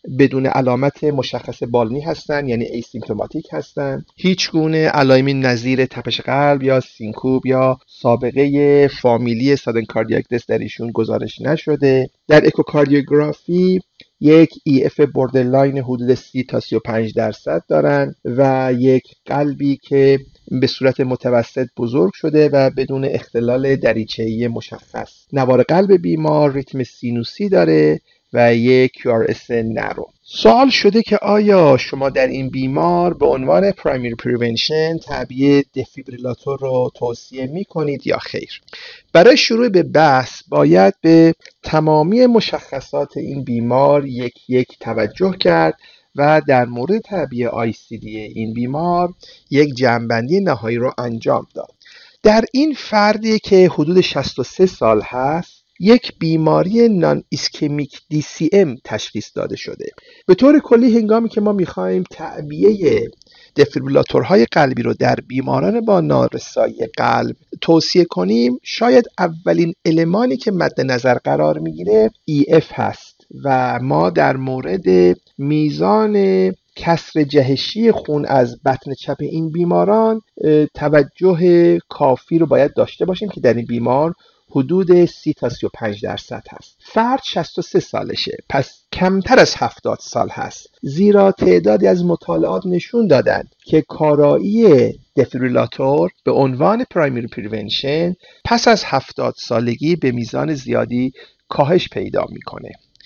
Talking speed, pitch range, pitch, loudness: 125 wpm, 125-175 Hz, 145 Hz, -16 LUFS